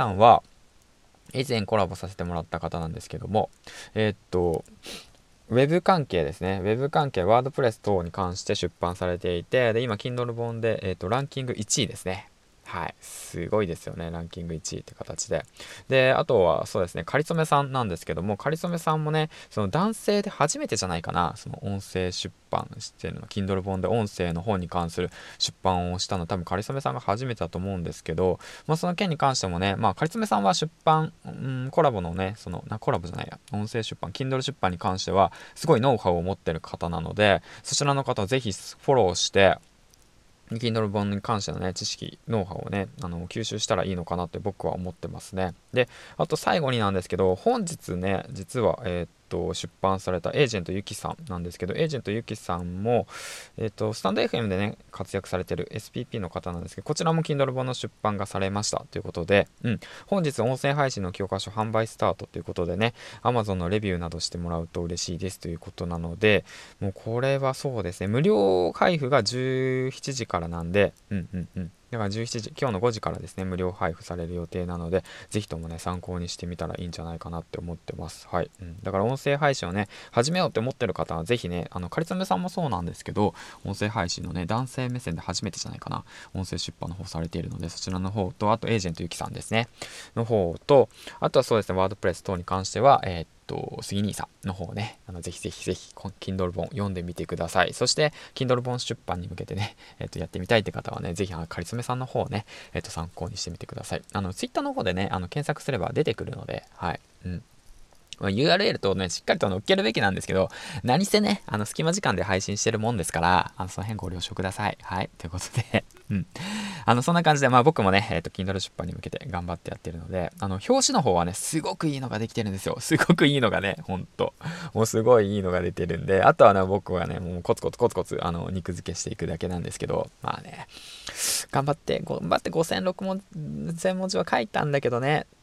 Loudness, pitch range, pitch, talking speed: -27 LUFS, 90-125 Hz, 100 Hz, 450 characters per minute